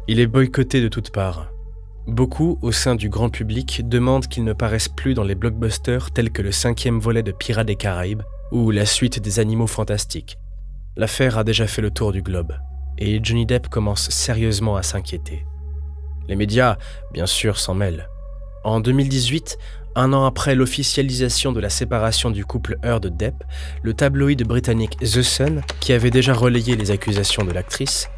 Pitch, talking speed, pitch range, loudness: 110 Hz, 170 wpm, 95-125 Hz, -20 LUFS